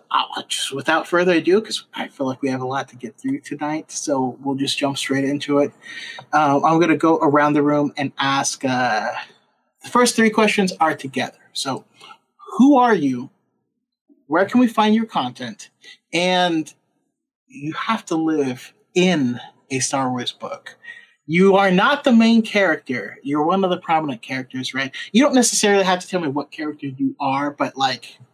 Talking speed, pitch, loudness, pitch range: 185 wpm, 155 Hz, -19 LUFS, 135-215 Hz